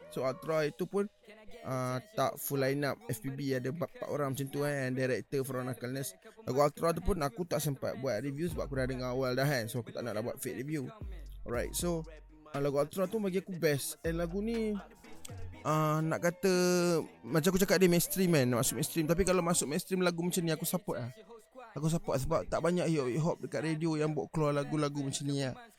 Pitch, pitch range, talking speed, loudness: 155 Hz, 135-180 Hz, 220 wpm, -33 LUFS